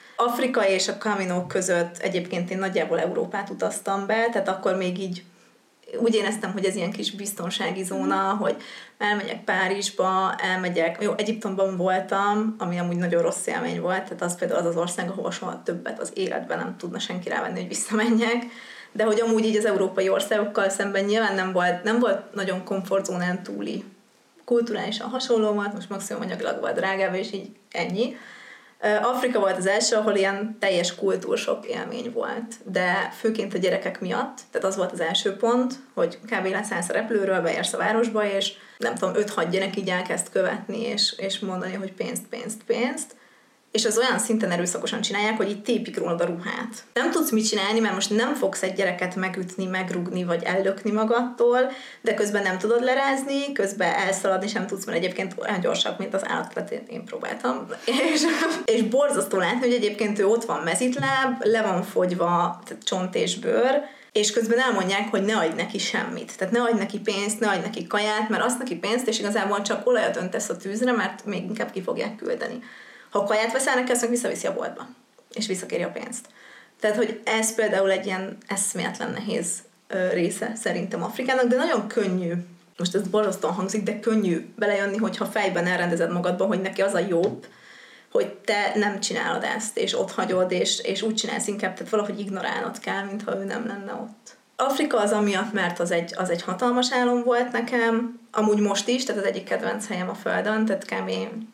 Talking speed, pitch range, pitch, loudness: 180 wpm, 190-230 Hz, 210 Hz, -25 LUFS